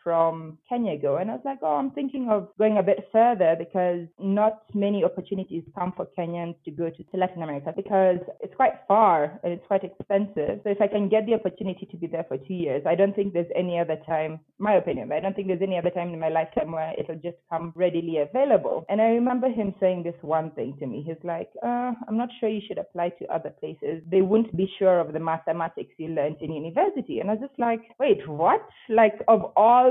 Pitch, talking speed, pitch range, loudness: 185 Hz, 235 wpm, 165-215 Hz, -25 LUFS